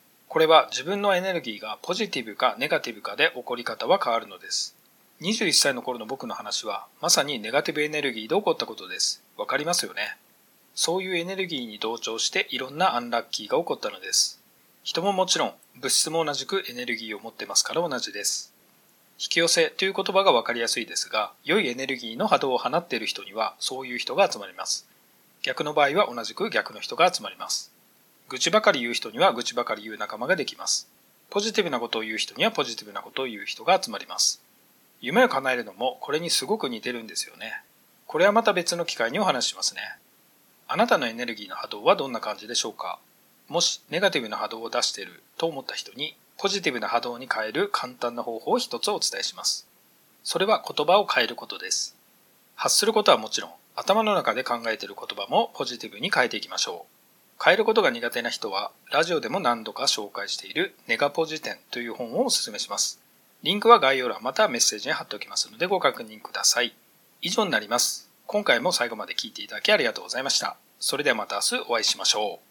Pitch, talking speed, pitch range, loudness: 160 Hz, 445 characters per minute, 120-195 Hz, -25 LUFS